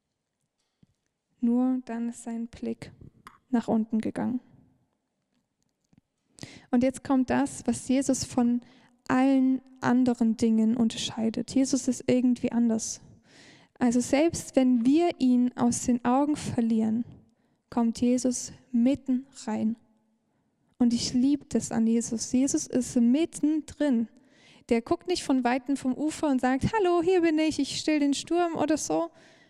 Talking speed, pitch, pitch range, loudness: 130 wpm, 250 Hz, 235-275 Hz, -27 LUFS